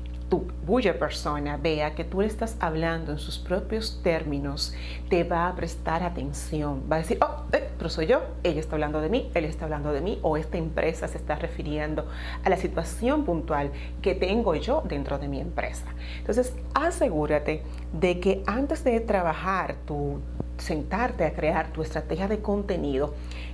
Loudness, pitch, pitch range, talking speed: -28 LUFS, 160 Hz, 145-185 Hz, 175 wpm